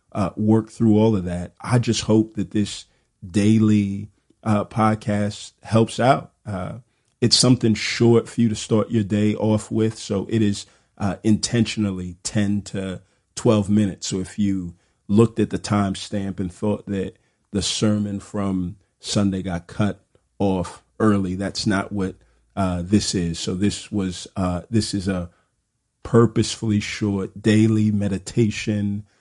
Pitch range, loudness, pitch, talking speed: 95-110 Hz, -21 LUFS, 105 Hz, 150 wpm